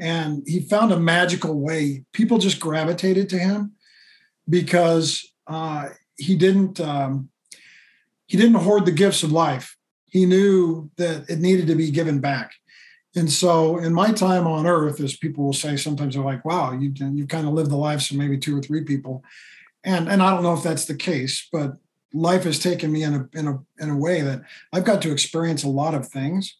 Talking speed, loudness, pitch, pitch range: 205 wpm, -21 LUFS, 160 Hz, 145-180 Hz